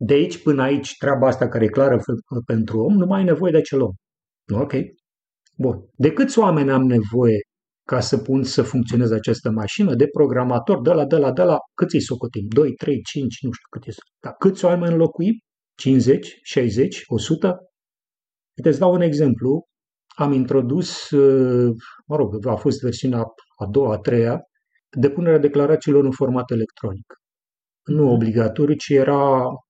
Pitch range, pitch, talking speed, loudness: 120-150 Hz, 135 Hz, 165 wpm, -19 LUFS